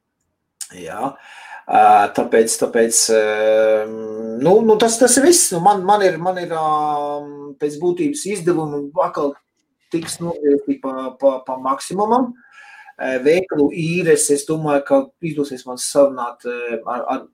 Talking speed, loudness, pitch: 130 wpm, -17 LUFS, 155 Hz